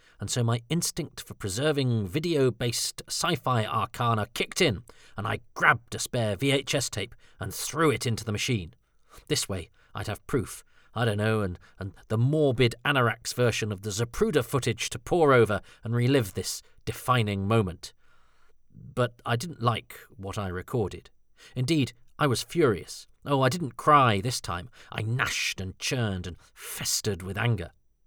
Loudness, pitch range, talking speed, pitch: -27 LUFS, 105-130 Hz, 165 wpm, 120 Hz